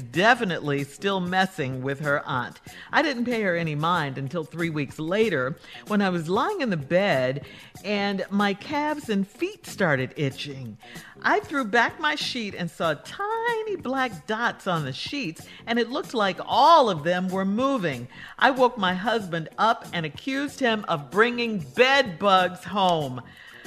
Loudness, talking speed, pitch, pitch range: -24 LUFS, 165 wpm, 190 Hz, 160-235 Hz